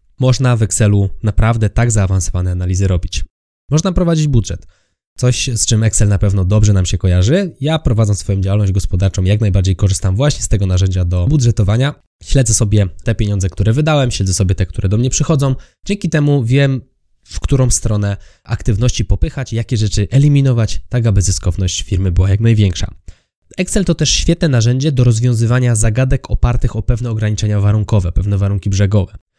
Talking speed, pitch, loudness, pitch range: 165 wpm, 110 Hz, -14 LUFS, 95-125 Hz